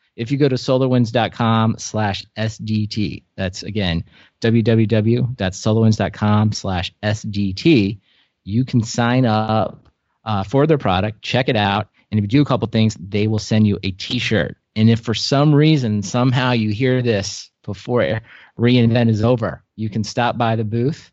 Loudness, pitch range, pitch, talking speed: -18 LUFS, 105-120 Hz, 110 Hz, 155 wpm